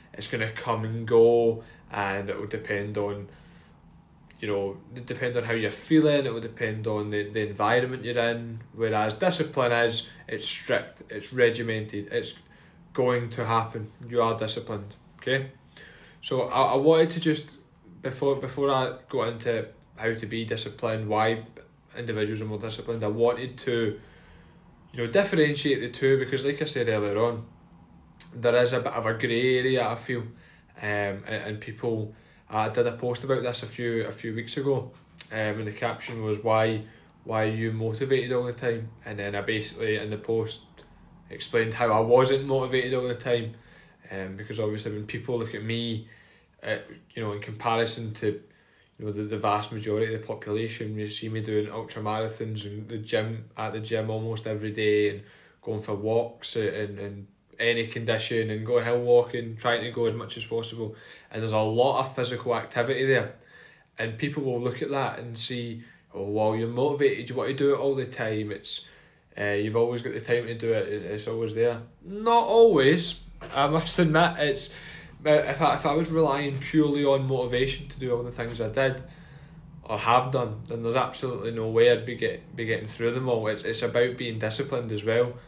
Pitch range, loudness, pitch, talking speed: 110-130 Hz, -27 LUFS, 115 Hz, 190 wpm